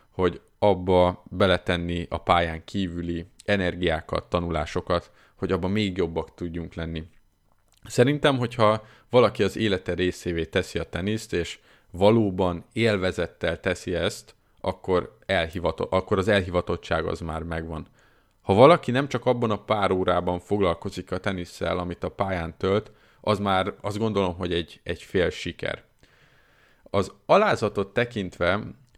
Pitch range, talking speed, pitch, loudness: 85-105 Hz, 130 wpm, 95 Hz, -25 LUFS